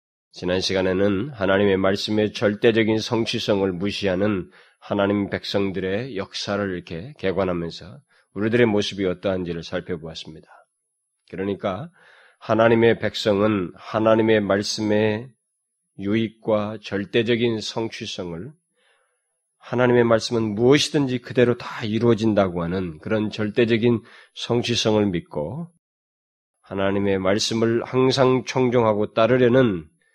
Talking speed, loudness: 285 characters per minute, -22 LUFS